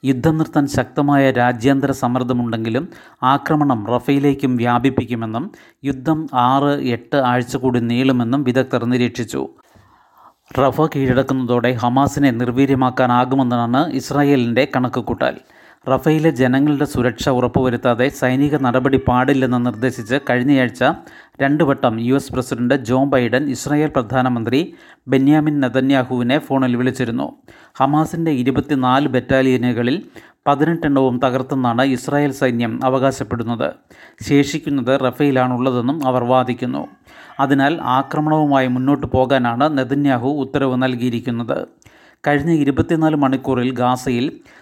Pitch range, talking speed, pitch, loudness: 125-140 Hz, 90 wpm, 130 Hz, -17 LUFS